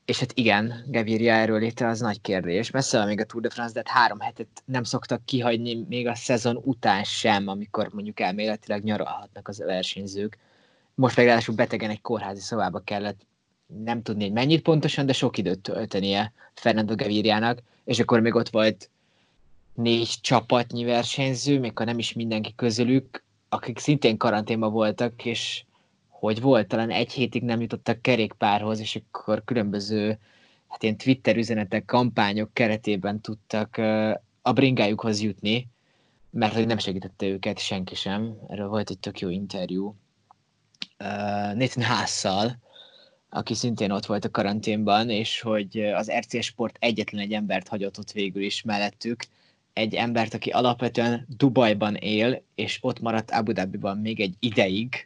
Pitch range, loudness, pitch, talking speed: 105-120 Hz, -25 LUFS, 110 Hz, 155 wpm